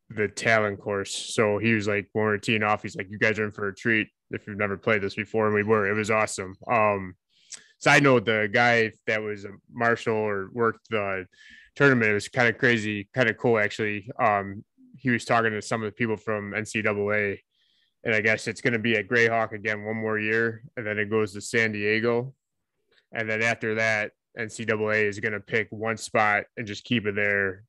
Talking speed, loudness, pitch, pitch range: 215 wpm, -25 LUFS, 110 Hz, 105-115 Hz